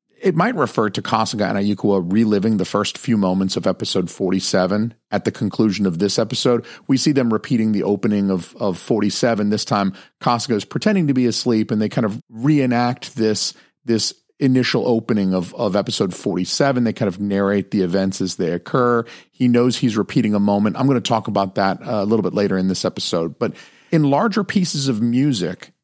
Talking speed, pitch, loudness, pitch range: 195 wpm, 110 Hz, -19 LUFS, 100-125 Hz